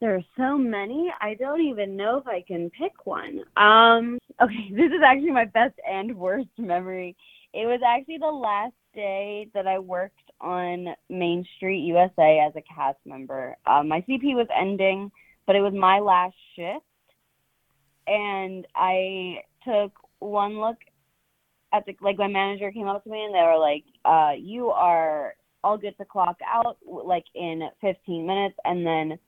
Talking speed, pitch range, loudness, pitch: 170 wpm, 180-225 Hz, -24 LUFS, 195 Hz